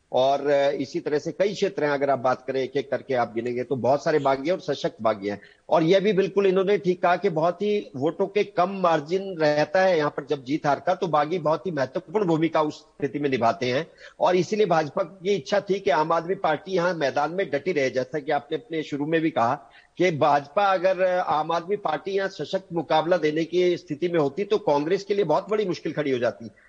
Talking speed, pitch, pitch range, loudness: 235 wpm, 160 Hz, 145-190 Hz, -24 LUFS